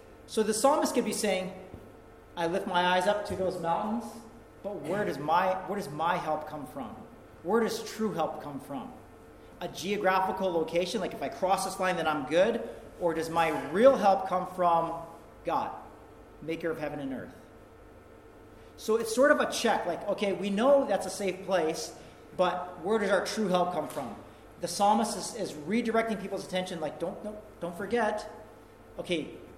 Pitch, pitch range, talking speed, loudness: 190 Hz, 170-215 Hz, 185 wpm, -29 LUFS